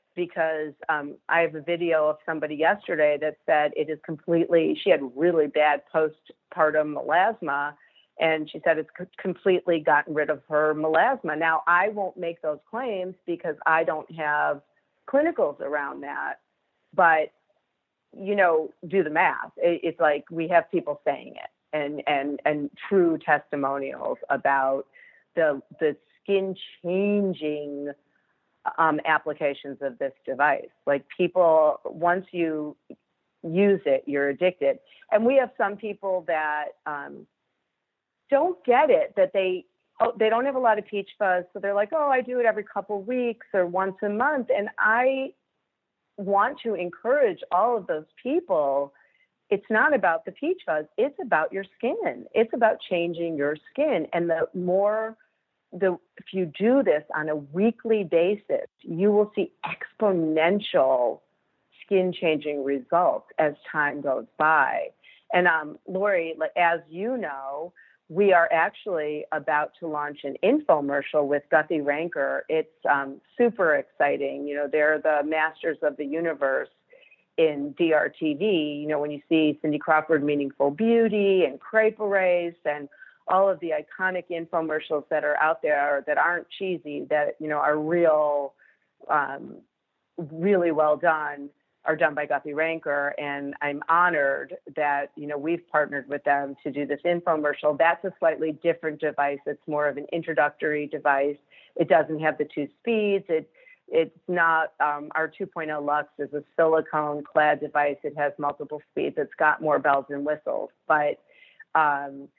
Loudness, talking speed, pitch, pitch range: -25 LUFS, 155 wpm, 160 Hz, 150-195 Hz